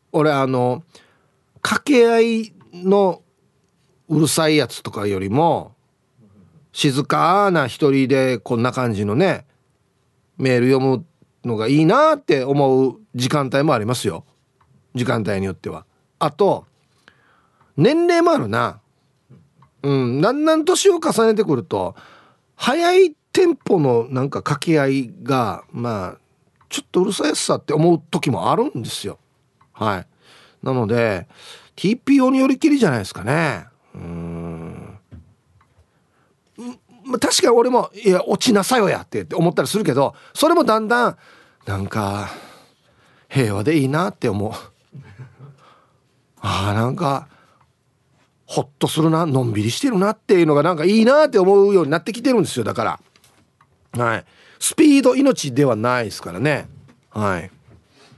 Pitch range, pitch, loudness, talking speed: 125-195 Hz, 140 Hz, -18 LUFS, 265 characters per minute